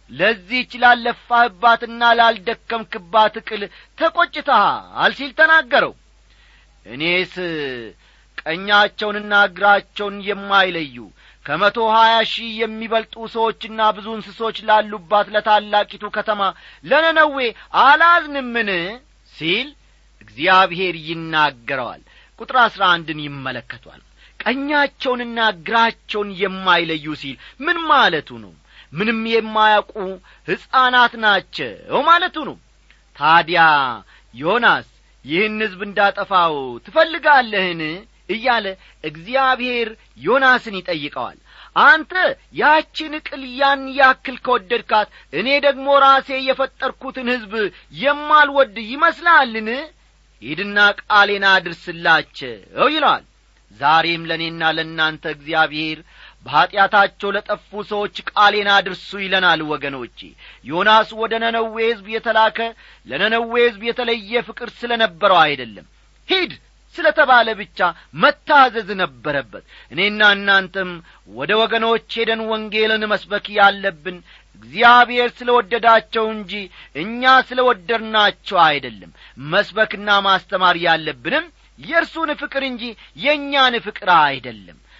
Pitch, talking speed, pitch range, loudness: 220 Hz, 90 wpm, 190-250 Hz, -17 LUFS